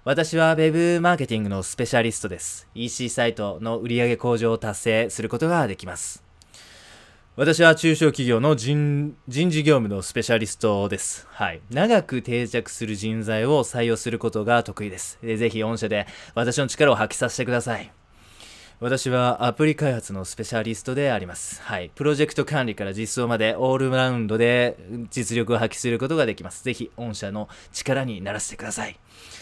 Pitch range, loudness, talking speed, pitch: 105-130 Hz, -23 LUFS, 365 characters per minute, 115 Hz